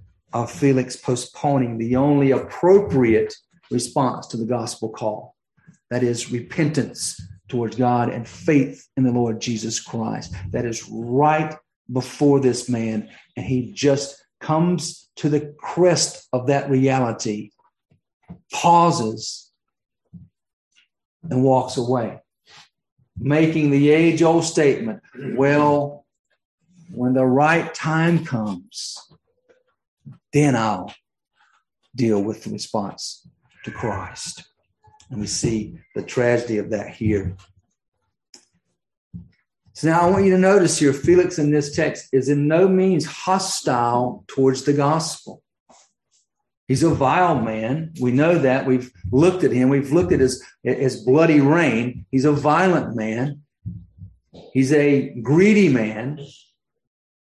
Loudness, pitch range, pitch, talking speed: -20 LUFS, 120-155 Hz, 135 Hz, 120 wpm